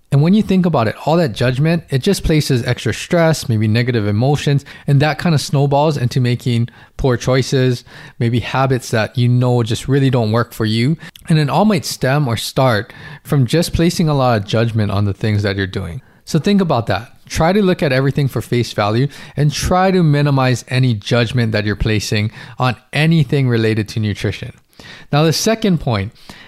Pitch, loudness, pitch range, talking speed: 130 Hz, -16 LUFS, 115-150 Hz, 195 wpm